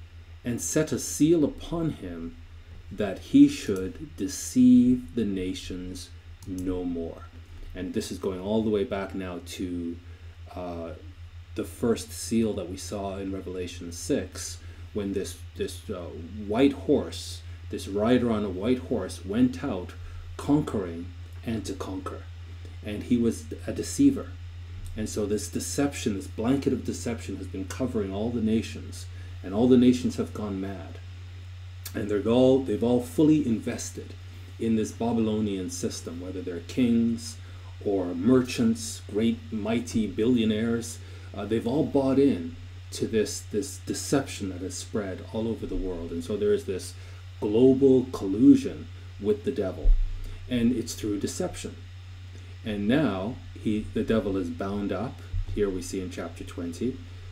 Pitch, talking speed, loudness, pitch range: 95 Hz, 150 wpm, -27 LUFS, 90-110 Hz